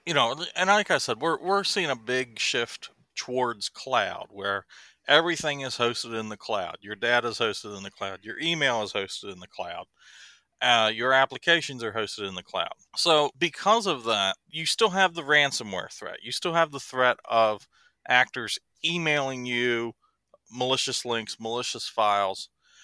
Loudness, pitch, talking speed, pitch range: -26 LUFS, 130 Hz, 175 wpm, 120-160 Hz